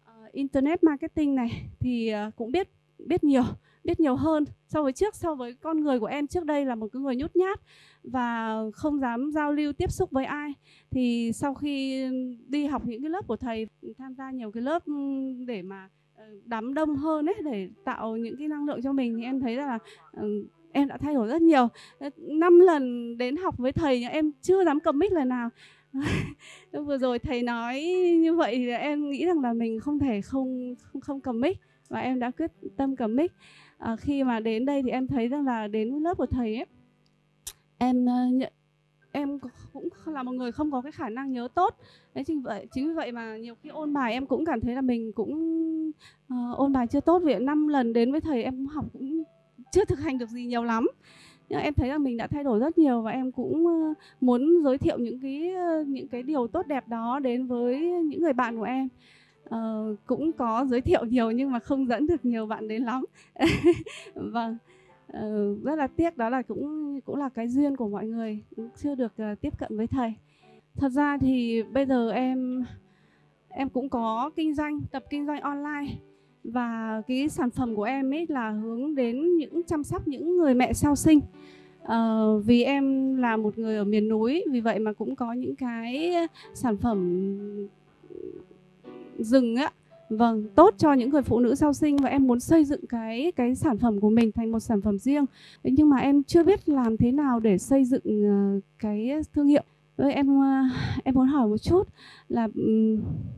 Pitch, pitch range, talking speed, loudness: 260 Hz, 230-295 Hz, 200 wpm, -26 LUFS